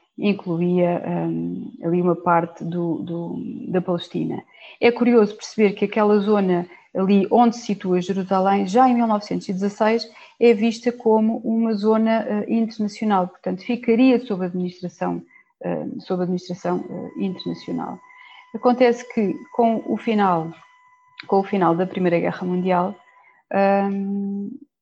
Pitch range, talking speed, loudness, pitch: 180-230 Hz, 125 wpm, -21 LUFS, 200 Hz